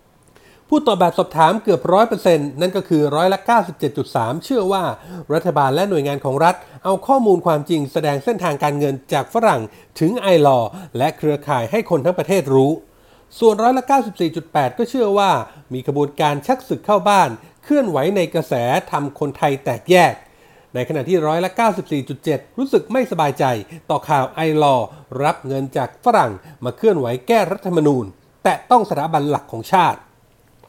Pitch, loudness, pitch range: 160 Hz, -18 LUFS, 145-195 Hz